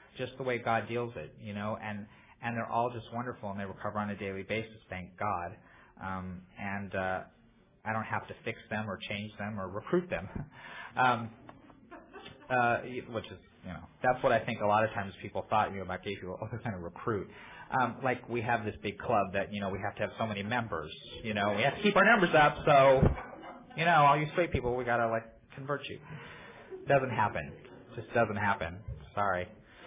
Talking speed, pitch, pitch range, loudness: 220 wpm, 110 Hz, 100-120 Hz, -32 LUFS